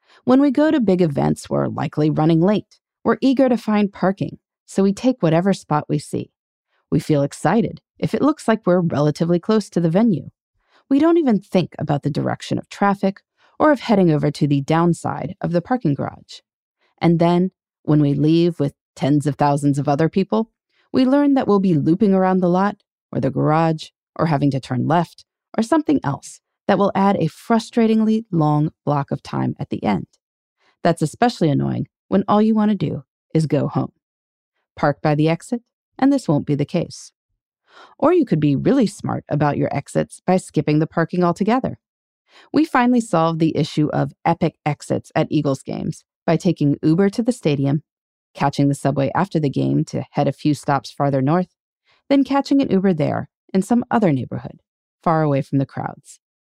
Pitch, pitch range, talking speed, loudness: 170 Hz, 145-210 Hz, 190 wpm, -19 LUFS